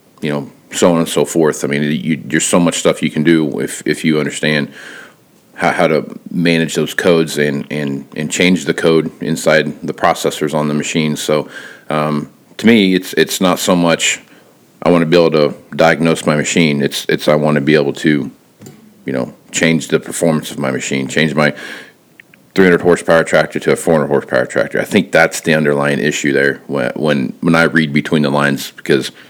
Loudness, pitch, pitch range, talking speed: -14 LUFS, 80 Hz, 75-85 Hz, 200 wpm